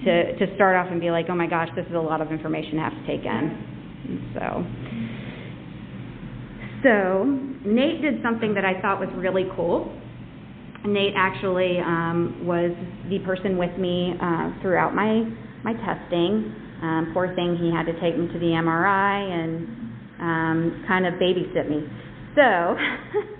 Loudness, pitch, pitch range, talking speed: -24 LUFS, 180 Hz, 170-195 Hz, 165 wpm